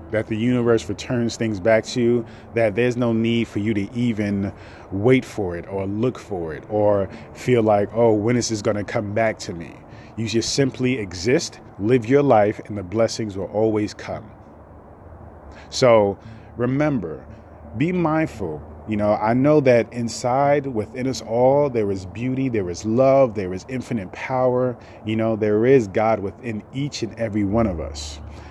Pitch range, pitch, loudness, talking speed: 105-125 Hz, 110 Hz, -21 LUFS, 175 wpm